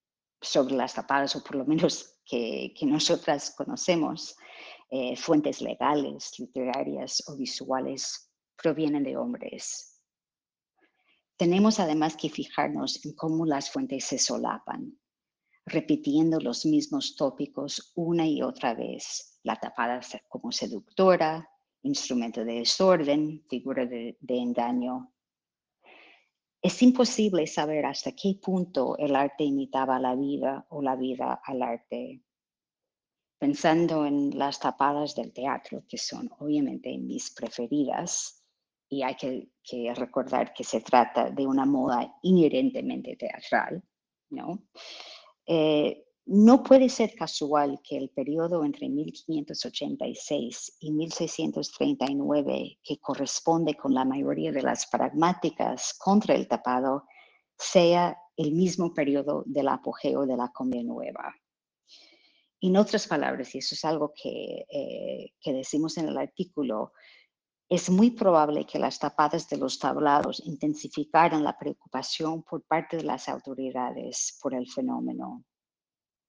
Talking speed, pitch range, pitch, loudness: 125 wpm, 135-195 Hz, 155 Hz, -28 LUFS